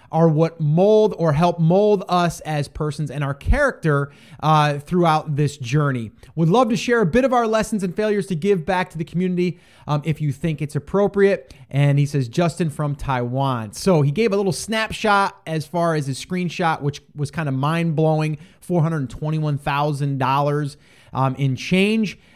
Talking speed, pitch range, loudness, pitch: 175 wpm, 145-185 Hz, -20 LUFS, 155 Hz